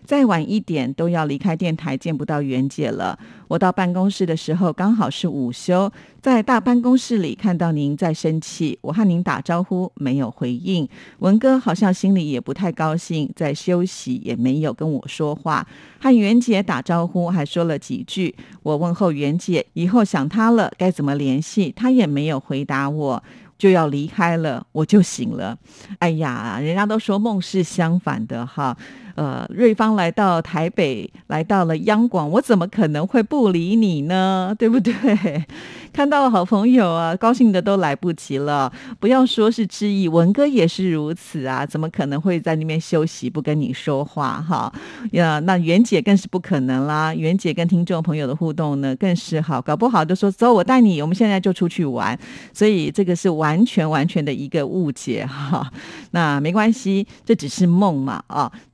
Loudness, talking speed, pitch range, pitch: -19 LUFS, 265 characters per minute, 155-205 Hz, 175 Hz